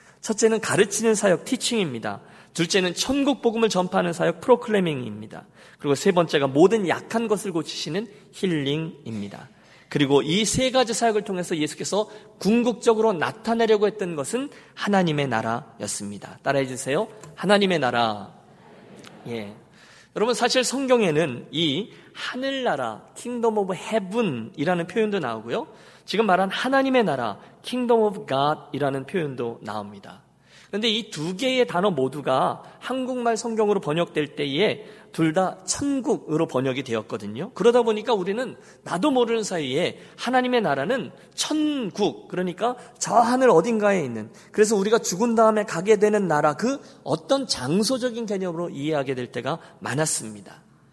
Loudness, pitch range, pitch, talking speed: -23 LUFS, 150-230 Hz, 200 Hz, 345 characters per minute